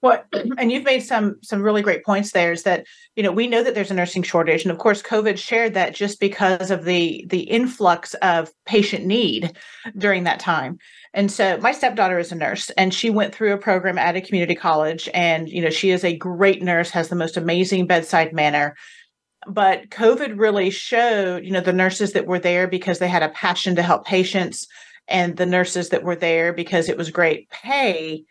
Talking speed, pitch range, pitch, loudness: 210 wpm, 175-210 Hz, 185 Hz, -20 LUFS